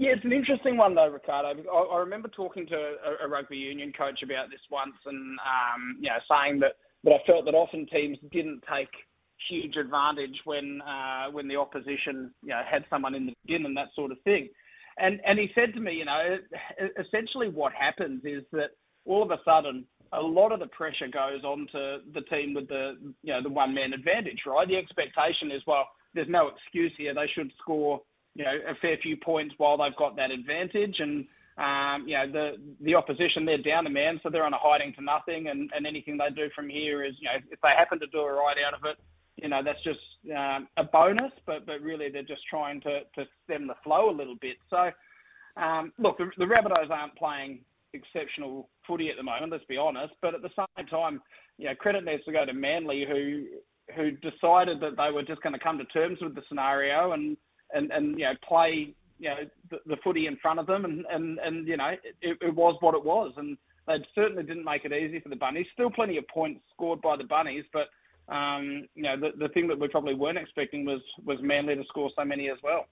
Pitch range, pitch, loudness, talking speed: 140-175 Hz, 150 Hz, -29 LUFS, 230 wpm